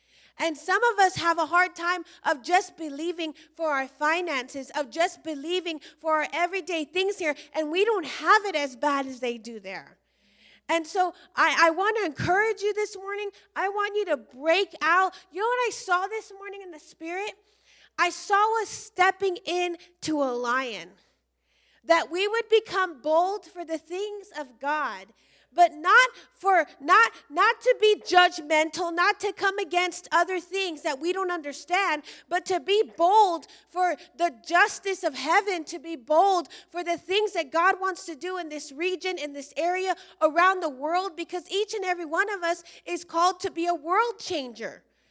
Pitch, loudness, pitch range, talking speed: 350 Hz, -25 LUFS, 315-385 Hz, 180 wpm